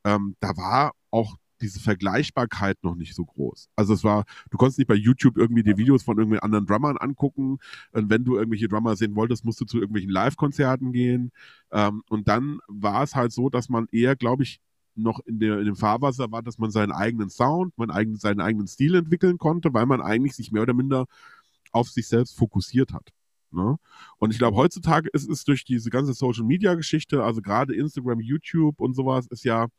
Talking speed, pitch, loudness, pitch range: 205 wpm, 120 Hz, -24 LUFS, 110-135 Hz